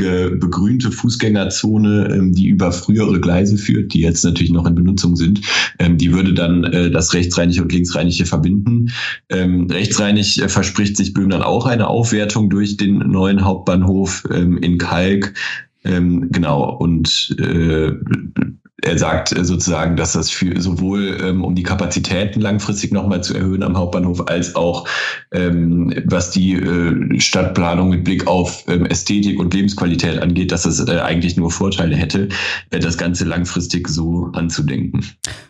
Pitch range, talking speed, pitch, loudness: 85-100 Hz, 130 wpm, 90 Hz, -16 LUFS